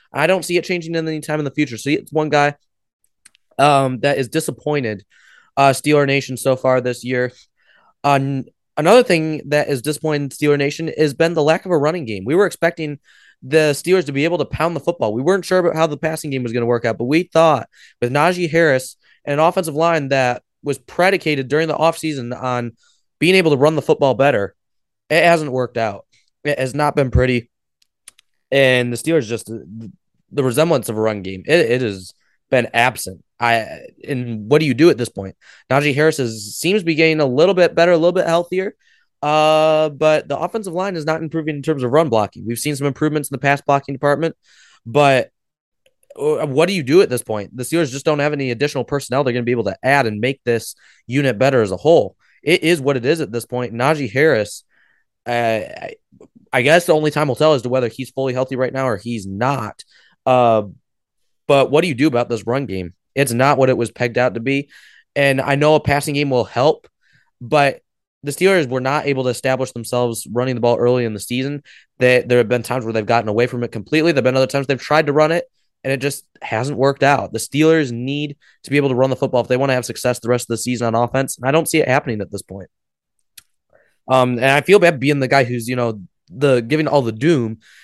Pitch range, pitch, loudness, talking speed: 125-155 Hz, 140 Hz, -17 LUFS, 230 wpm